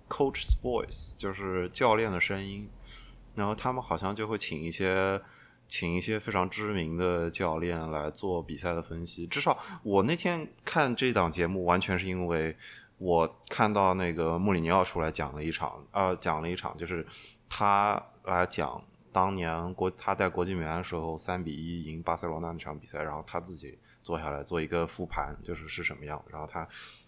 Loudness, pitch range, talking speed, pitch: -31 LUFS, 80-95 Hz, 295 characters per minute, 90 Hz